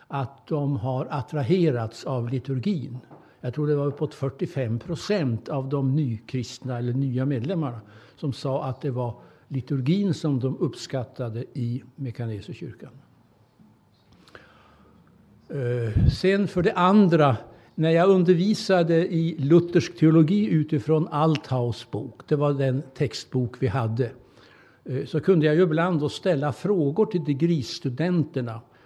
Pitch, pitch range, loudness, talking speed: 140 Hz, 125-165 Hz, -24 LUFS, 125 wpm